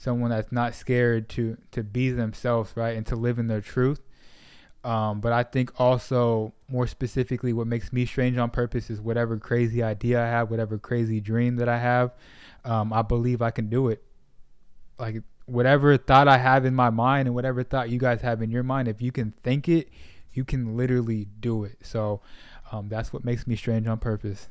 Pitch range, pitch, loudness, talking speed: 110-125 Hz, 120 Hz, -25 LUFS, 205 wpm